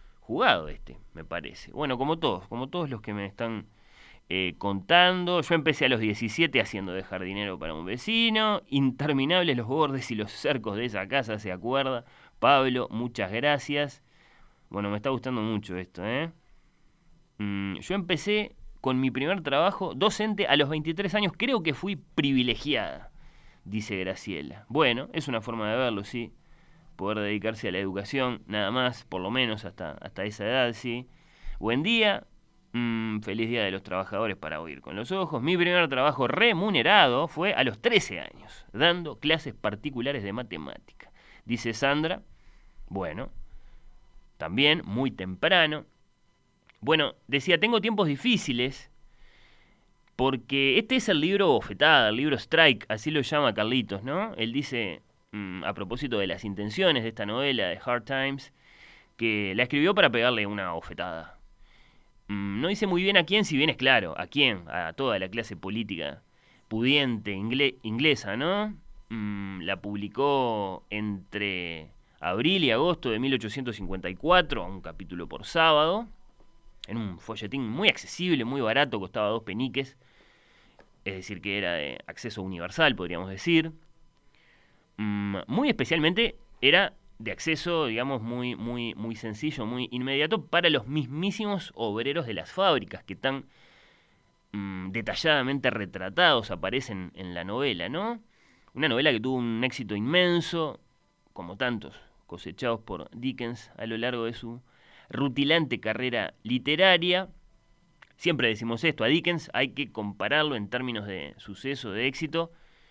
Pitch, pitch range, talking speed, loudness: 125 Hz, 105-155 Hz, 145 wpm, -27 LUFS